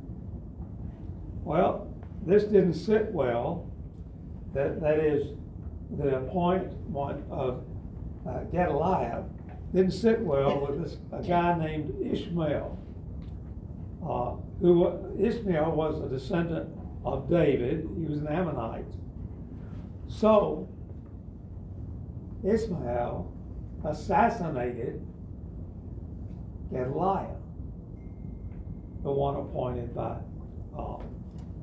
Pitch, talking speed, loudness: 100 Hz, 80 wpm, -29 LUFS